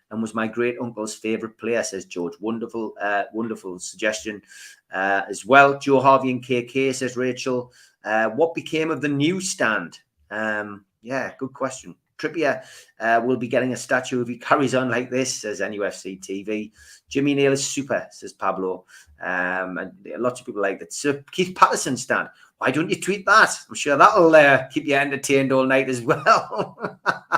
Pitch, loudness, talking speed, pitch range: 125 Hz, -21 LUFS, 180 wpm, 105-135 Hz